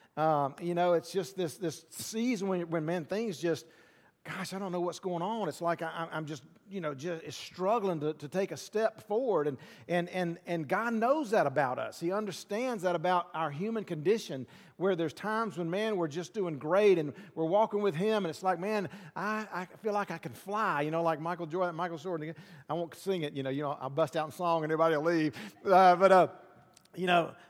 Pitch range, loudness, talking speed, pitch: 160-195 Hz, -32 LUFS, 225 wpm, 175 Hz